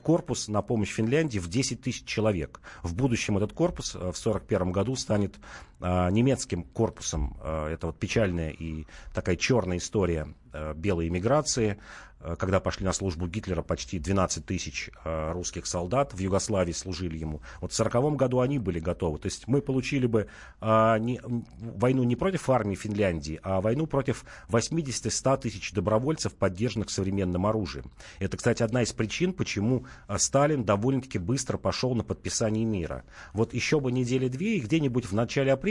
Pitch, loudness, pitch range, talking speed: 105 Hz, -28 LUFS, 90-125 Hz, 150 wpm